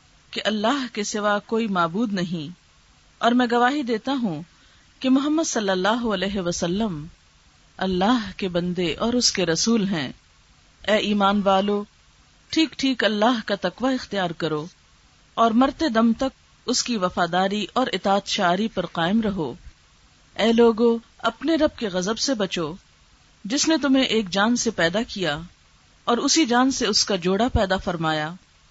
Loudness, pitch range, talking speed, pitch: -22 LUFS, 185-240 Hz, 155 wpm, 210 Hz